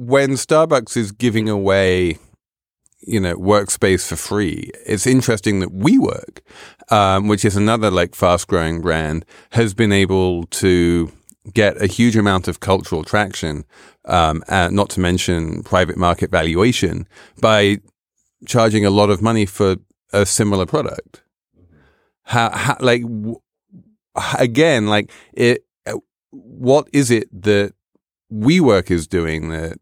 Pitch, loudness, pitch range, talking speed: 100 Hz, -17 LUFS, 90-115 Hz, 130 wpm